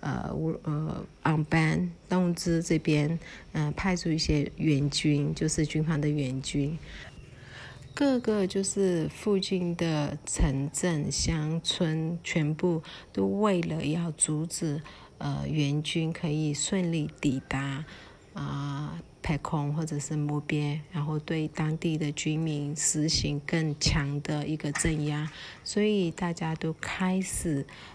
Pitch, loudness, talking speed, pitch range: 155 Hz, -29 LUFS, 185 characters per minute, 150-170 Hz